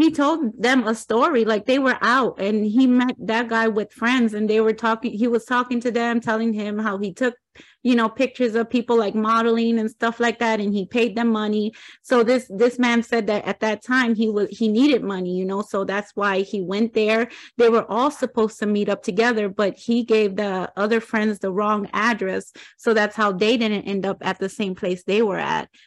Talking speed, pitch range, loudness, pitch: 230 wpm, 210-235 Hz, -21 LUFS, 225 Hz